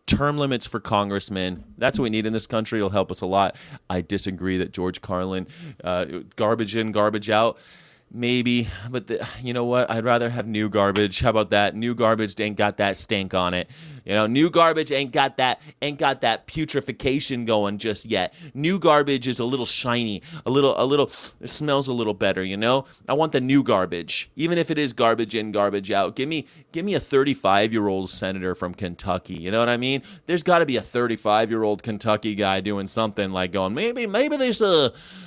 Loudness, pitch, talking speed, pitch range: -23 LUFS, 115 Hz, 215 wpm, 100-135 Hz